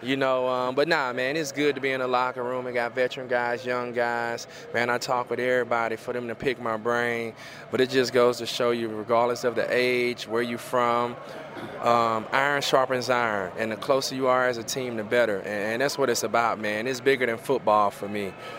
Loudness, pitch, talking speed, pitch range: -25 LUFS, 120 Hz, 230 wpm, 115-125 Hz